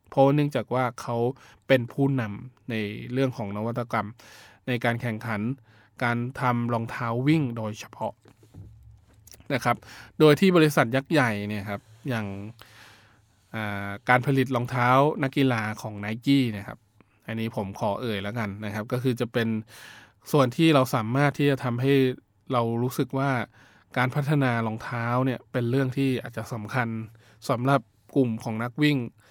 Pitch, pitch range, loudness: 120 Hz, 110-130 Hz, -26 LUFS